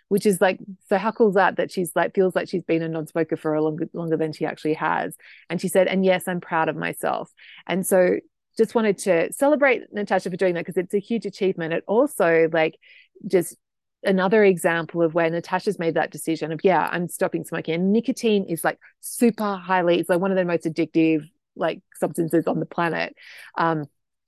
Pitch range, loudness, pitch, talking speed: 165-195 Hz, -22 LUFS, 180 Hz, 210 wpm